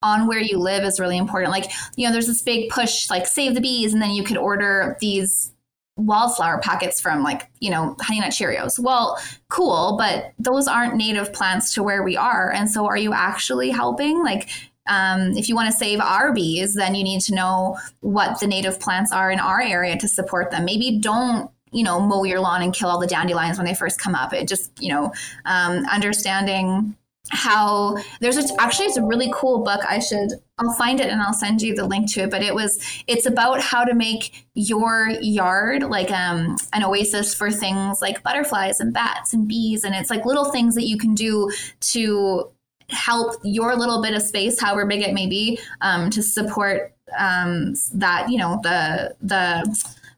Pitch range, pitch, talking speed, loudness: 190-235 Hz, 210 Hz, 205 wpm, -20 LUFS